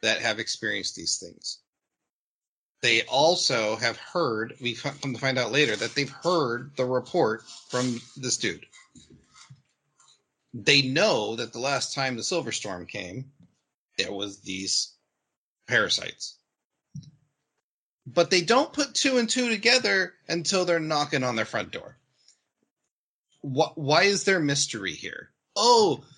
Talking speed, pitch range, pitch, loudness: 130 wpm, 125-170 Hz, 140 Hz, -25 LUFS